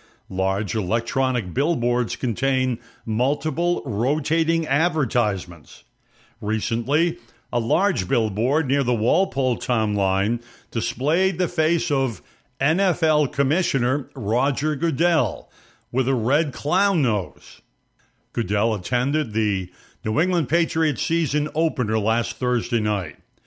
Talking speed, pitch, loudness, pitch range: 100 wpm, 125 Hz, -22 LUFS, 115-155 Hz